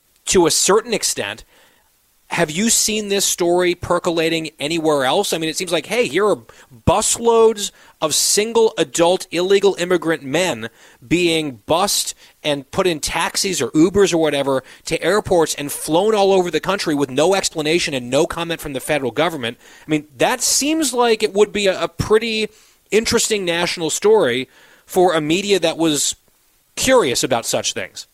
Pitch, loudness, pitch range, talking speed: 175 Hz, -17 LUFS, 155-210 Hz, 165 wpm